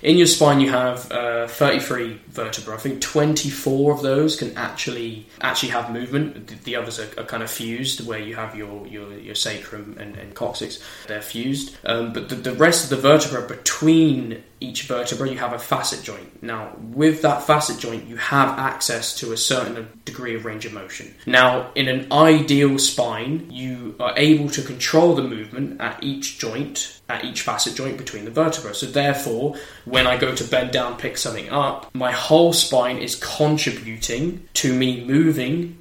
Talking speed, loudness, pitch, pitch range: 185 wpm, -20 LUFS, 130 Hz, 115-145 Hz